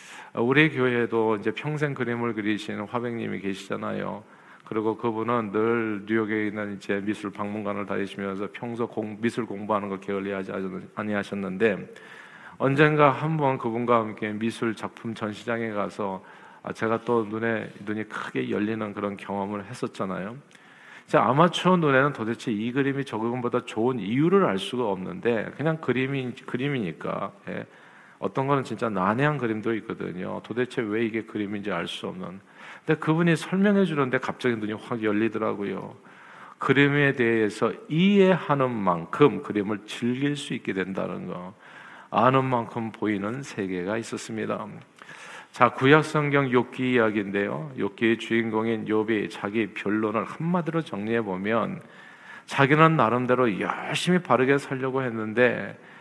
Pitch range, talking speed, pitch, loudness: 105-130 Hz, 325 characters per minute, 115 Hz, -26 LUFS